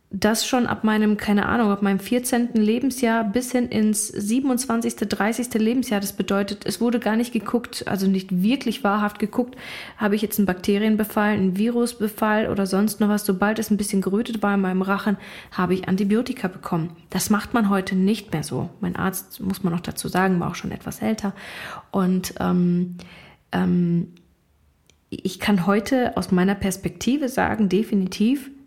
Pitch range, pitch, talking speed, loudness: 190-225 Hz, 205 Hz, 170 wpm, -22 LUFS